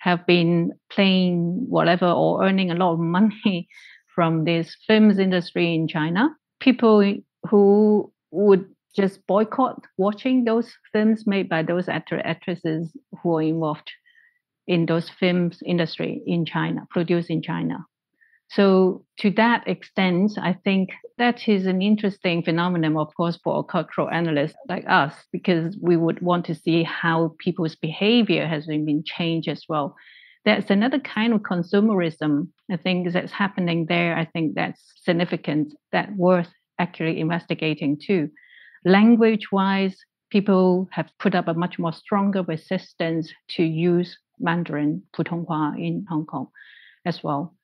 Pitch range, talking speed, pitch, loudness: 165-200 Hz, 140 wpm, 180 Hz, -22 LUFS